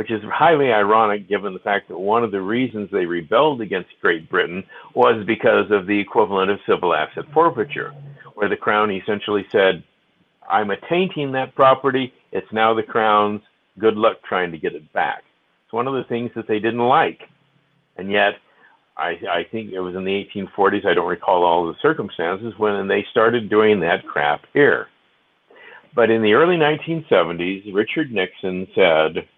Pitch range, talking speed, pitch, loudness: 100-125 Hz, 180 wpm, 110 Hz, -19 LUFS